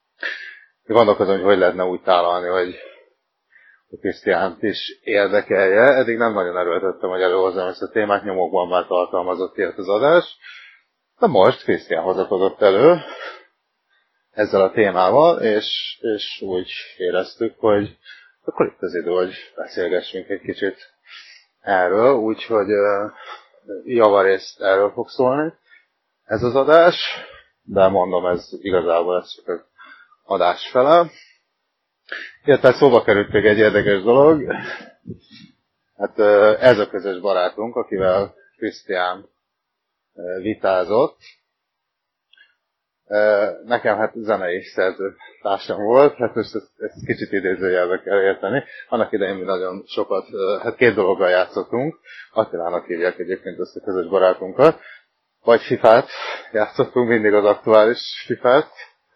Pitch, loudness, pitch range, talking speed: 105 Hz, -18 LUFS, 95-130 Hz, 115 wpm